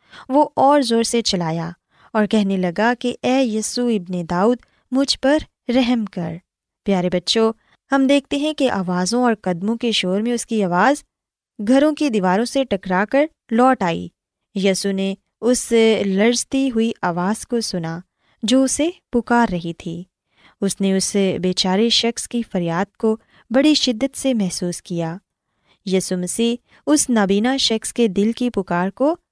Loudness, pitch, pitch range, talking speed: -19 LUFS, 220 Hz, 185-250 Hz, 160 wpm